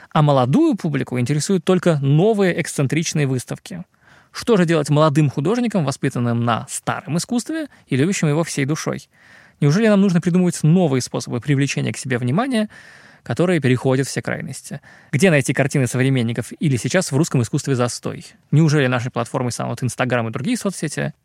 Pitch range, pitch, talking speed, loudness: 130-175 Hz, 150 Hz, 155 wpm, -19 LUFS